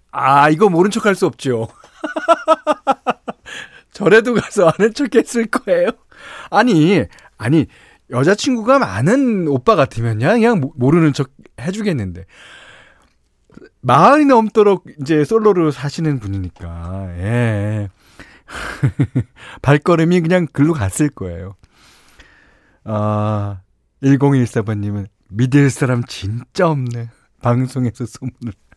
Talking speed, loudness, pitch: 220 characters per minute, -15 LUFS, 140 Hz